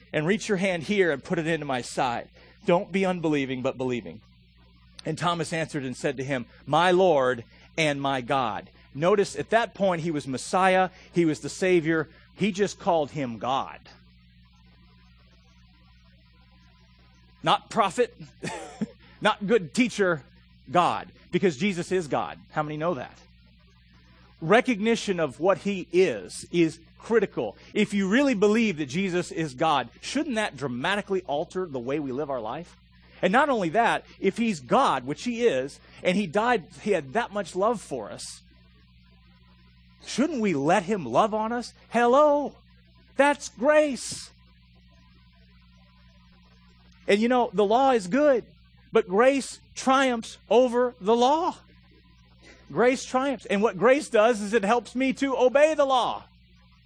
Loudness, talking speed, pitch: -25 LUFS, 150 wpm, 170 Hz